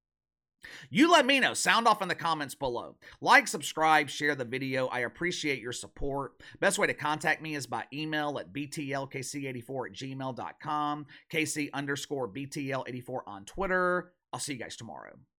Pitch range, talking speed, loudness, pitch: 130-155 Hz, 160 wpm, -30 LUFS, 145 Hz